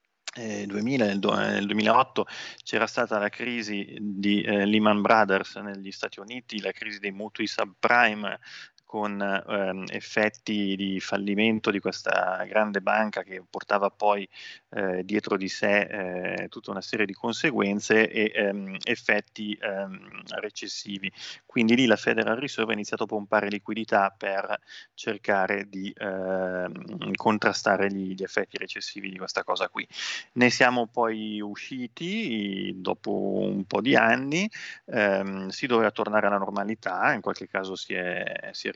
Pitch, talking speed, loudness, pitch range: 105 Hz, 140 wpm, -26 LUFS, 100-110 Hz